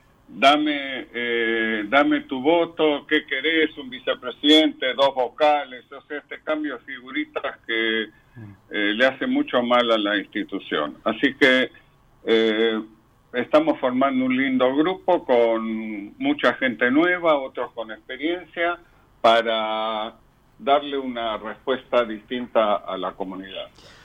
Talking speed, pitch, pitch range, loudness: 120 wpm, 130 Hz, 115-150 Hz, -22 LUFS